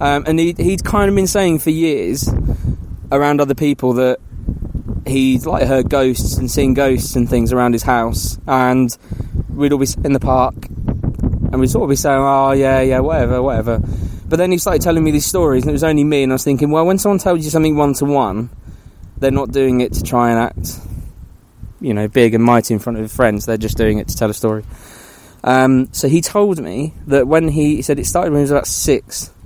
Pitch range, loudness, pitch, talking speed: 120-150 Hz, -15 LUFS, 135 Hz, 225 wpm